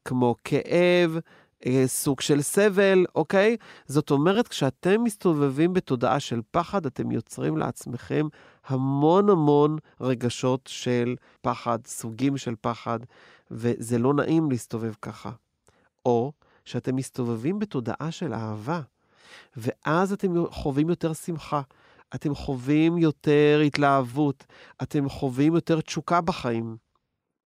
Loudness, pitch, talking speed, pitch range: -25 LUFS, 145 Hz, 105 wpm, 125-165 Hz